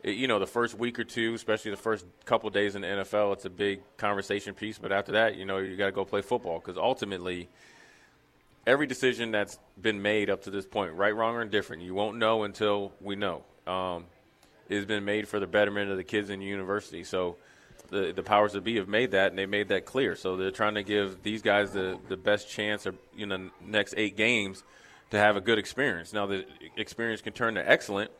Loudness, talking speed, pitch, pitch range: -29 LUFS, 235 wpm, 105 Hz, 95-110 Hz